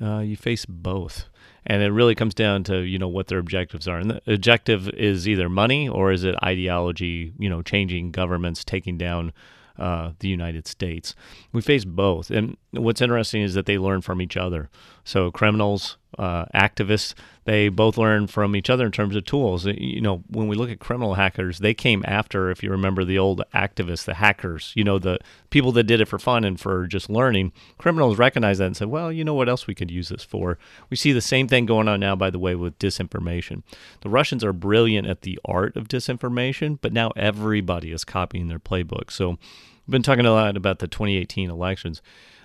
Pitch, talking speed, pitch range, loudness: 100 Hz, 205 wpm, 90-110 Hz, -22 LUFS